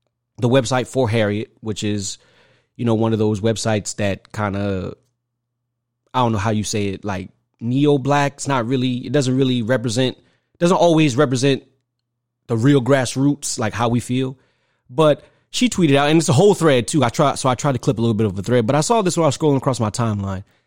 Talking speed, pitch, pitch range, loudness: 220 wpm, 125 Hz, 115-140 Hz, -19 LUFS